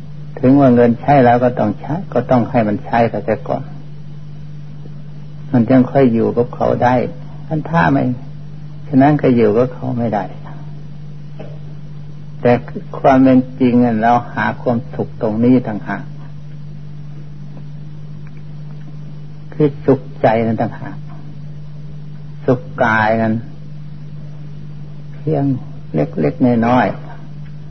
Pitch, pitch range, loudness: 150 Hz, 125-150 Hz, -15 LUFS